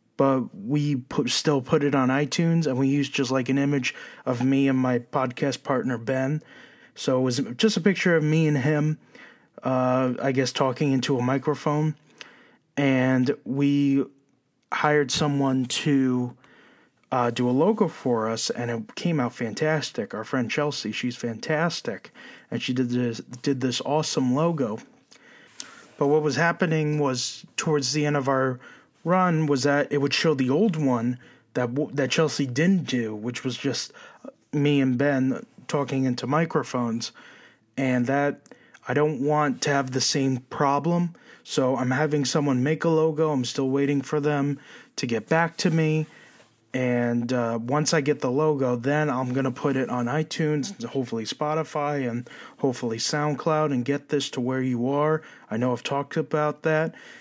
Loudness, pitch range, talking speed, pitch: -25 LUFS, 130-150 Hz, 170 wpm, 140 Hz